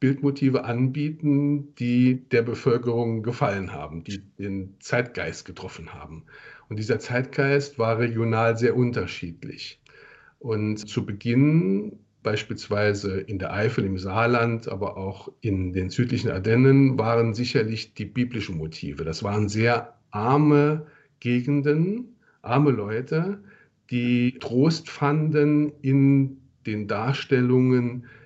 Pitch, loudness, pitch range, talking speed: 120 Hz, -24 LUFS, 110-140 Hz, 110 wpm